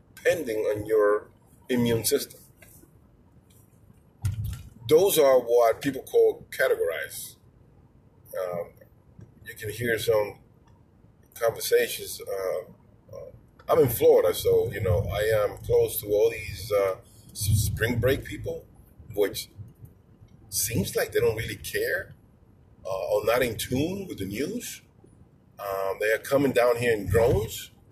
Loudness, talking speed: -26 LUFS, 125 wpm